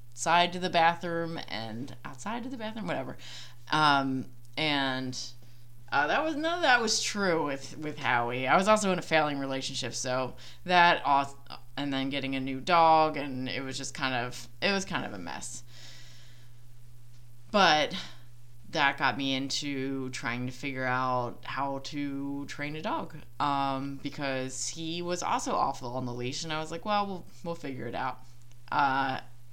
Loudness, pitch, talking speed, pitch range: -29 LUFS, 135 Hz, 170 wpm, 120-160 Hz